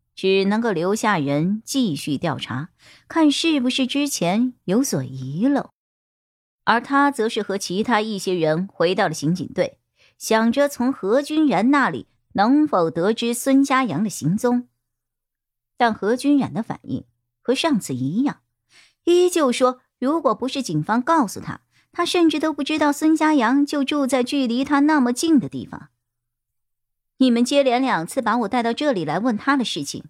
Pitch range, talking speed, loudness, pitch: 185-280 Hz, 235 characters per minute, -20 LUFS, 240 Hz